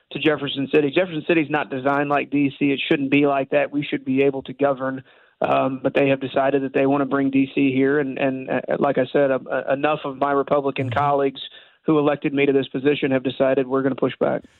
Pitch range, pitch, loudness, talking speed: 135-145 Hz, 140 Hz, -21 LUFS, 240 wpm